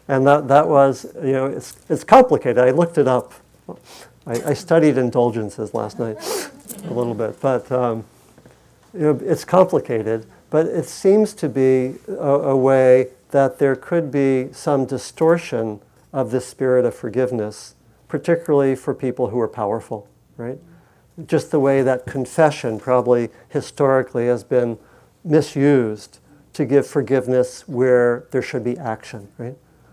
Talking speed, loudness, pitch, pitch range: 145 wpm, -19 LUFS, 130 Hz, 120-145 Hz